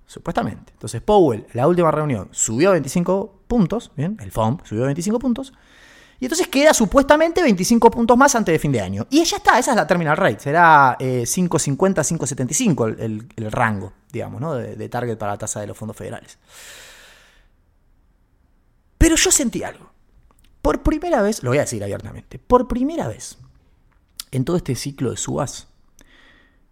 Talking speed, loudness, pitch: 170 wpm, -18 LUFS, 150 Hz